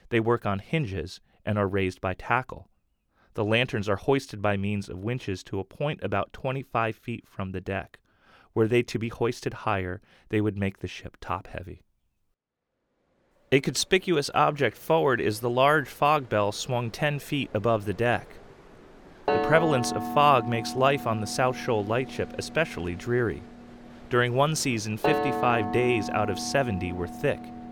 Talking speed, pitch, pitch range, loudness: 170 wpm, 115 Hz, 100-130 Hz, -27 LUFS